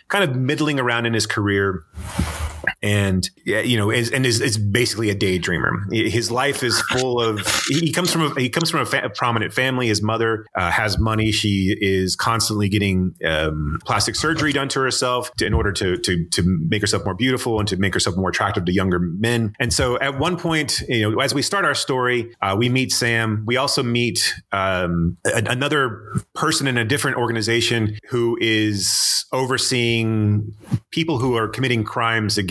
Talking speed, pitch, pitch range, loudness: 195 wpm, 115 Hz, 100-125 Hz, -20 LUFS